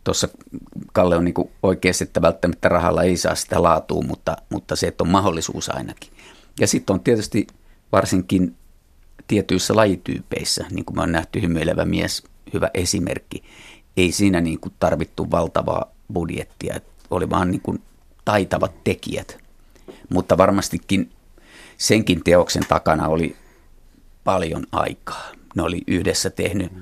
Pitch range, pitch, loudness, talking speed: 80-95 Hz, 90 Hz, -21 LUFS, 130 wpm